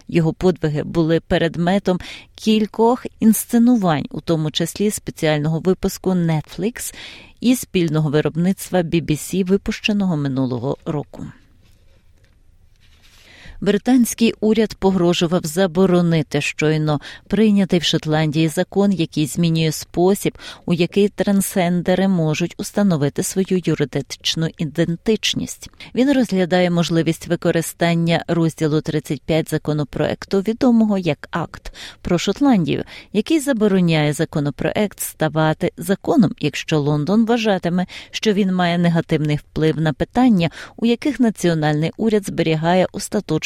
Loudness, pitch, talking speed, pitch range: -19 LUFS, 170 Hz, 100 wpm, 155-200 Hz